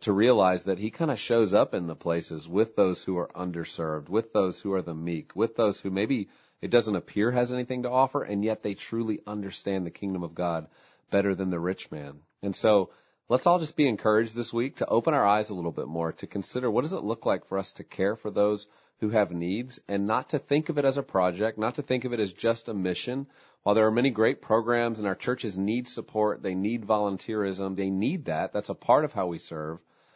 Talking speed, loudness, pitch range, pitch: 245 wpm, -28 LUFS, 95-115 Hz, 105 Hz